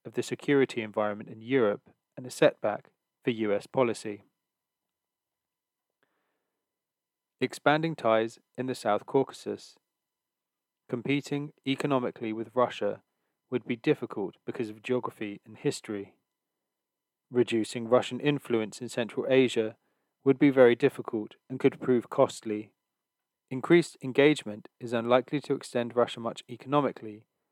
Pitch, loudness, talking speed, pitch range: 125 Hz, -29 LUFS, 115 wpm, 110-135 Hz